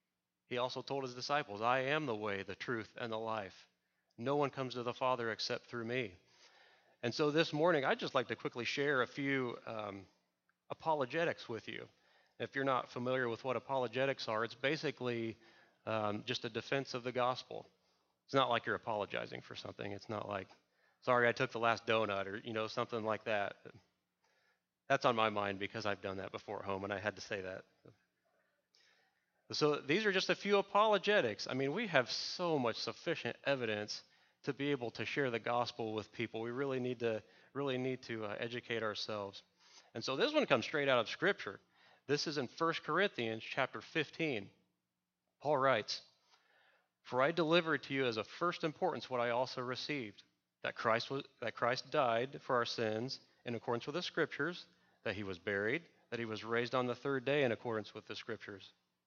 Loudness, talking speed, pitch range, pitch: -37 LUFS, 195 wpm, 110-135 Hz, 120 Hz